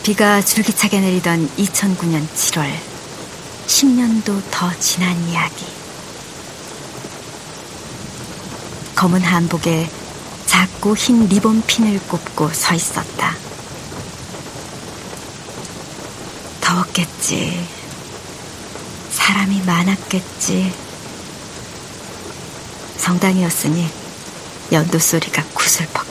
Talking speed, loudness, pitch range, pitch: 145 characters per minute, -16 LUFS, 170-200 Hz, 180 Hz